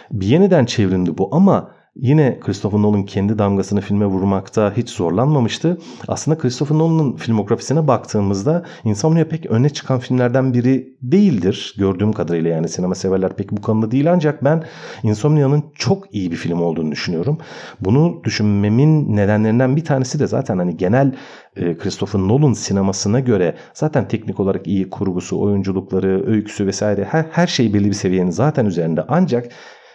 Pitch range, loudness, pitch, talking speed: 100-145 Hz, -17 LUFS, 110 Hz, 150 wpm